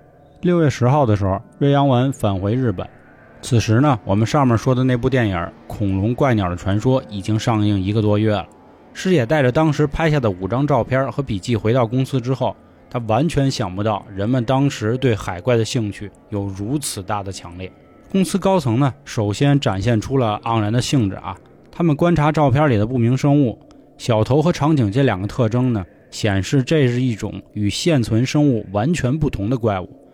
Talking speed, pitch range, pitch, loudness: 290 characters per minute, 105-140 Hz, 120 Hz, -19 LUFS